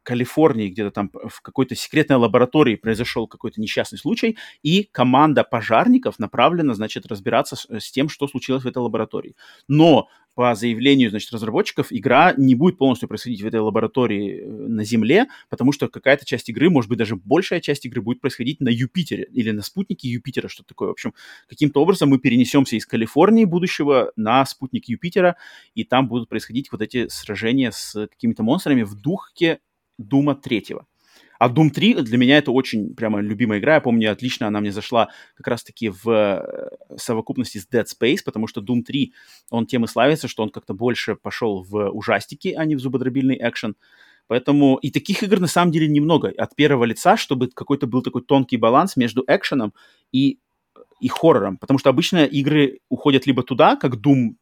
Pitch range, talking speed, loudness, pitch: 115-150 Hz, 180 wpm, -19 LUFS, 130 Hz